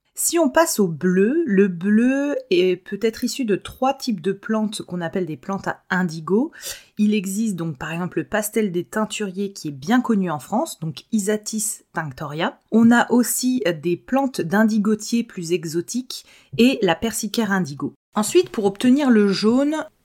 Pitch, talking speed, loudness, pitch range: 210 Hz, 170 wpm, -21 LUFS, 180-235 Hz